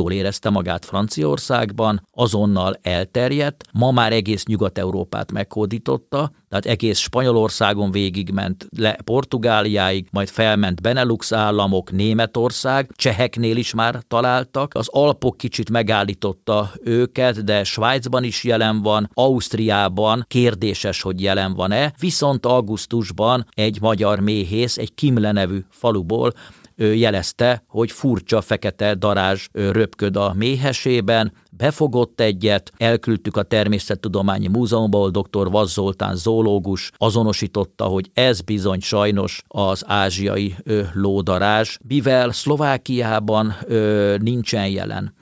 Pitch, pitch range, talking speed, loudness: 110 Hz, 100-120 Hz, 105 wpm, -19 LUFS